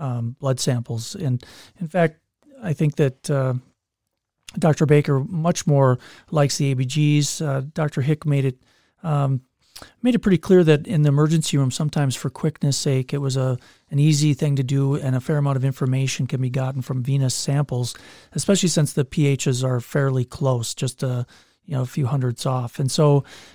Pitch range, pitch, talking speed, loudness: 130-150 Hz, 140 Hz, 185 wpm, -21 LUFS